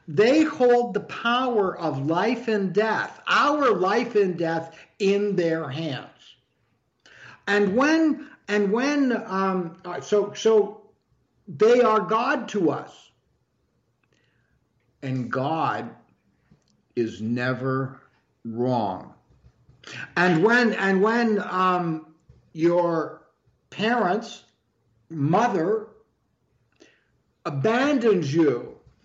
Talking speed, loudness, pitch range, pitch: 85 wpm, -23 LUFS, 155-225 Hz, 195 Hz